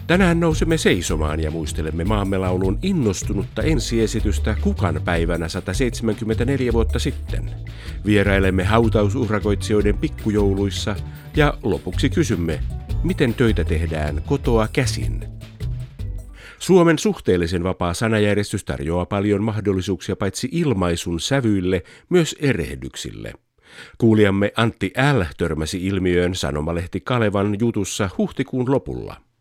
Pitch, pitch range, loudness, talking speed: 100 Hz, 90-115 Hz, -21 LUFS, 95 wpm